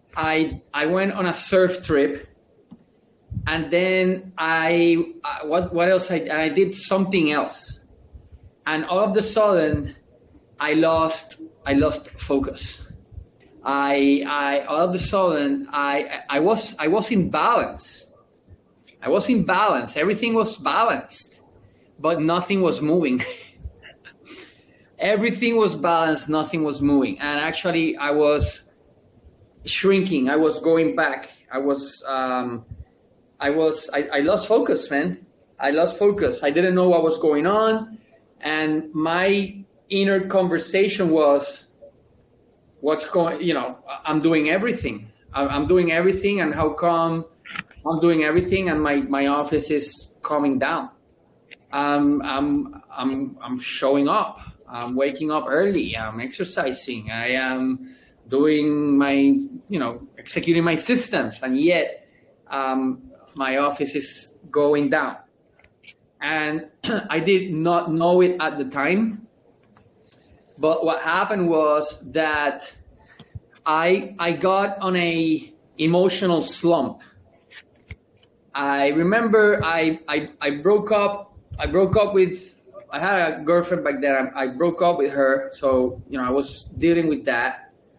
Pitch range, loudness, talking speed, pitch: 140-185 Hz, -21 LUFS, 135 wpm, 160 Hz